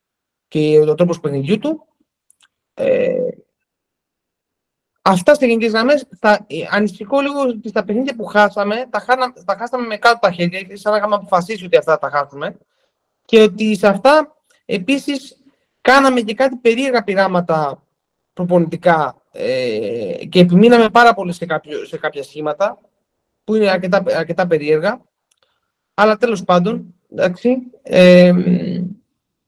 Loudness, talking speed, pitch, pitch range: -15 LUFS, 135 wpm, 210 Hz, 180-255 Hz